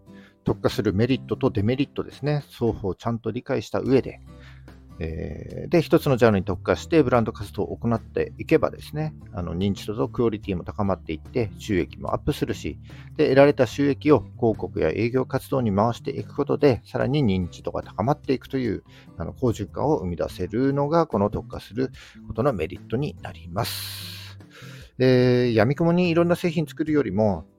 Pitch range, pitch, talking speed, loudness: 100-135 Hz, 115 Hz, 375 characters per minute, -24 LUFS